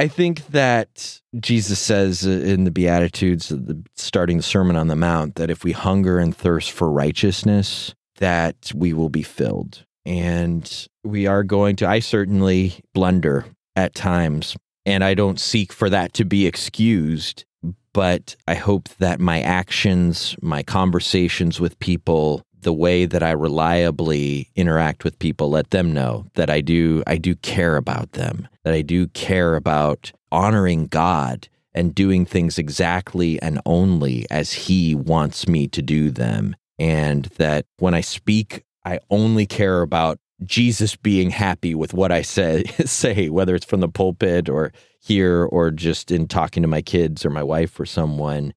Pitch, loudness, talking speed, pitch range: 90 Hz, -20 LUFS, 160 wpm, 80-100 Hz